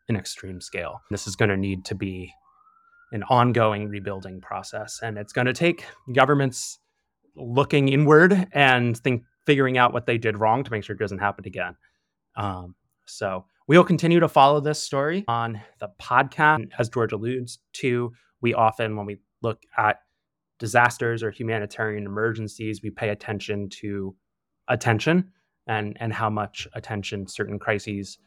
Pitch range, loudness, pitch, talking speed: 105-130 Hz, -23 LUFS, 115 Hz, 155 wpm